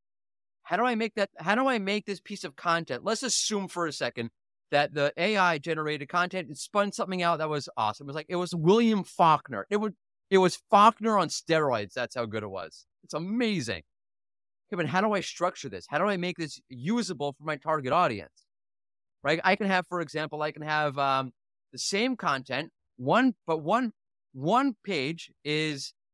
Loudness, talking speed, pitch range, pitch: -28 LUFS, 200 wpm, 145-200 Hz, 170 Hz